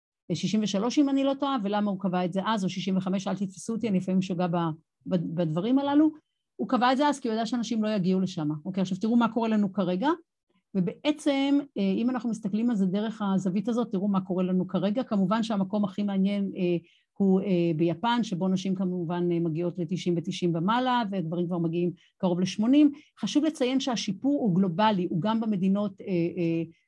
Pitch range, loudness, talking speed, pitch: 180-230 Hz, -27 LUFS, 185 wpm, 195 Hz